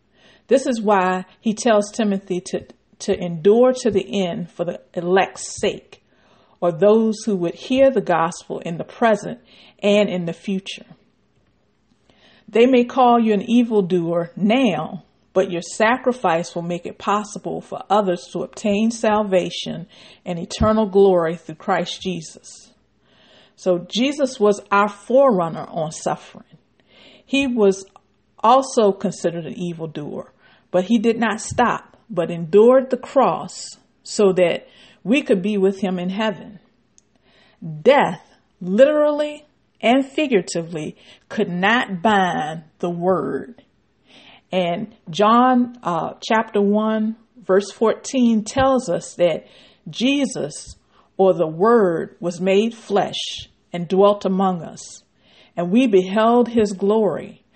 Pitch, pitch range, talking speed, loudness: 200 Hz, 180-225 Hz, 125 wpm, -19 LUFS